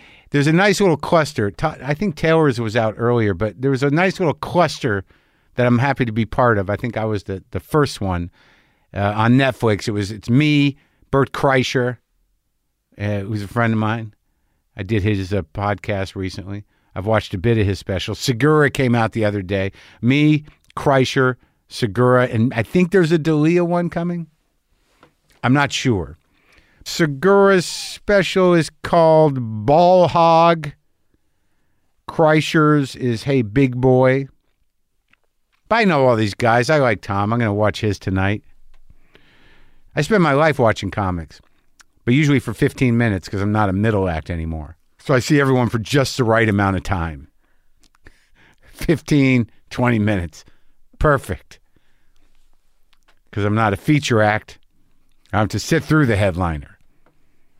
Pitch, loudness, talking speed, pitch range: 120 Hz, -18 LUFS, 160 wpm, 100-145 Hz